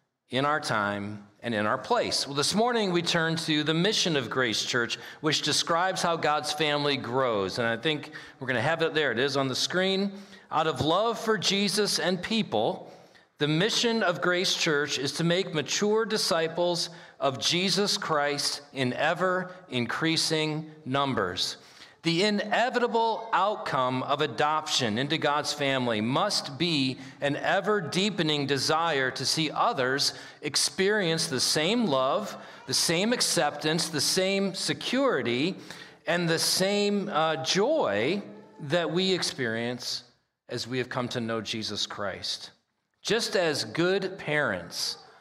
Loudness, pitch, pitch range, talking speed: -27 LUFS, 155 Hz, 135-185 Hz, 145 wpm